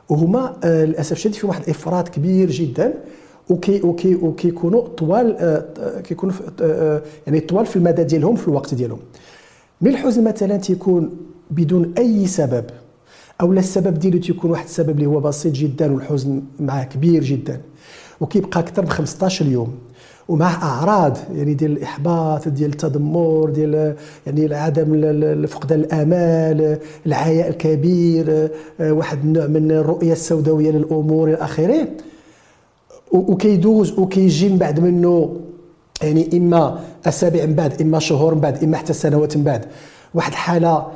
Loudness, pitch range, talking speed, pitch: -17 LUFS, 155-175 Hz, 135 wpm, 160 Hz